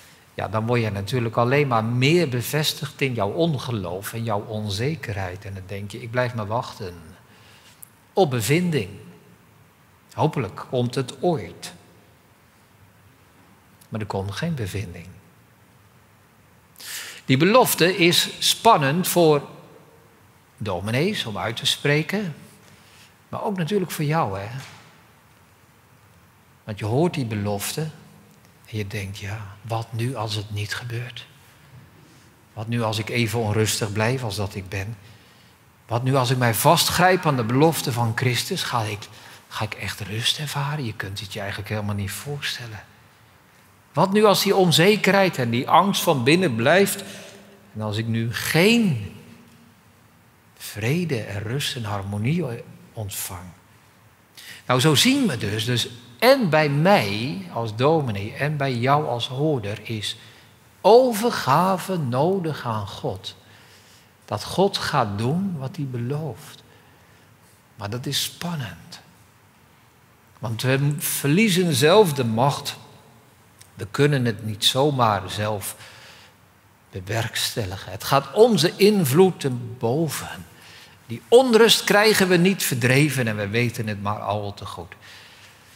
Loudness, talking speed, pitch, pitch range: -21 LUFS, 130 wpm, 120 Hz, 105-150 Hz